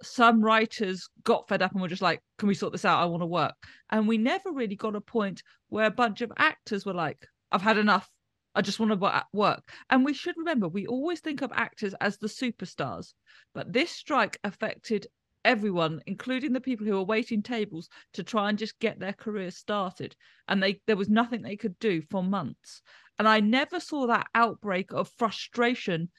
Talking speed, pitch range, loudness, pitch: 205 wpm, 195-235 Hz, -28 LUFS, 215 Hz